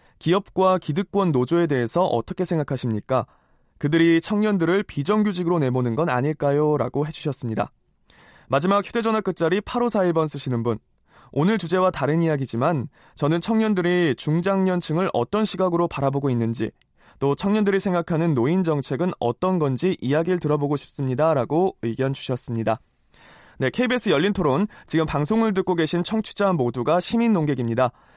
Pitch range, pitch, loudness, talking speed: 135-190 Hz, 165 Hz, -22 LUFS, 360 characters per minute